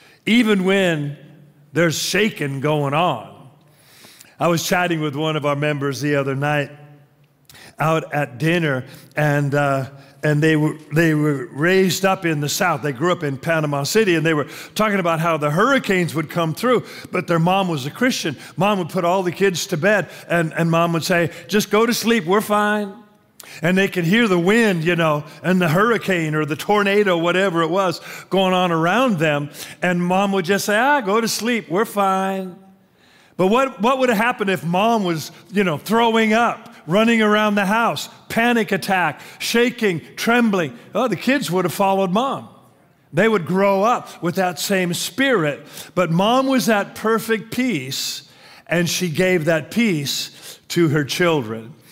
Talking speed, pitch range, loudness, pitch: 180 wpm, 155-205 Hz, -19 LUFS, 180 Hz